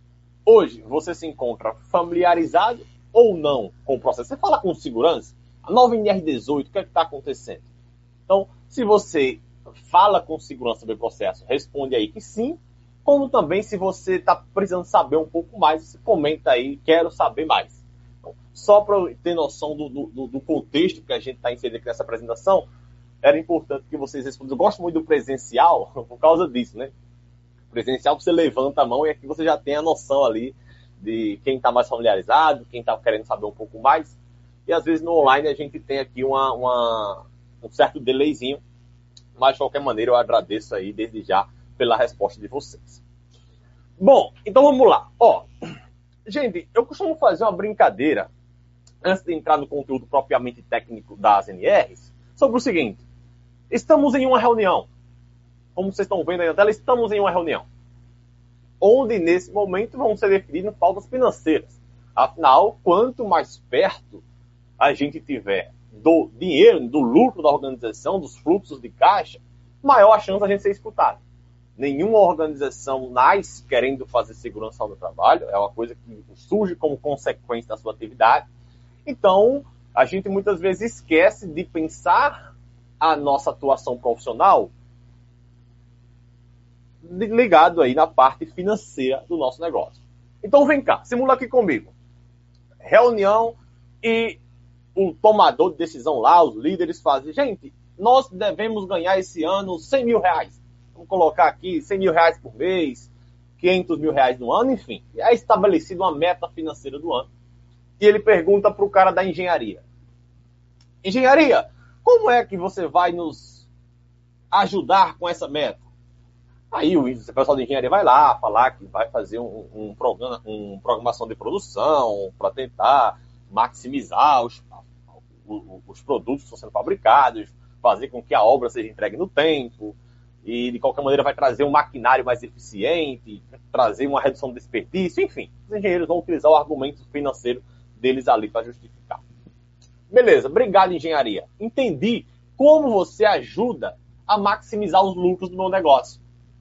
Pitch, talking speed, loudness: 135 Hz, 155 wpm, -20 LUFS